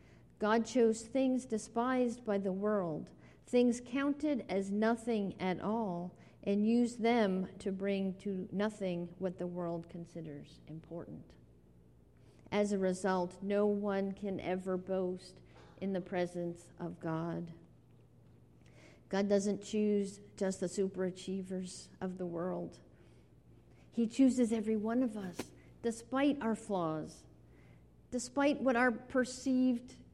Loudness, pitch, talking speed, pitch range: -35 LUFS, 200 Hz, 120 wpm, 180-230 Hz